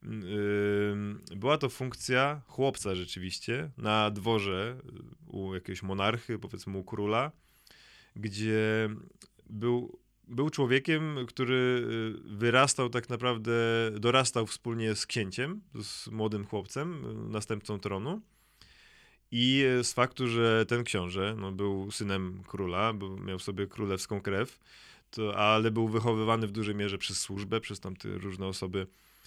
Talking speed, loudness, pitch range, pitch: 120 wpm, -31 LUFS, 100-120 Hz, 110 Hz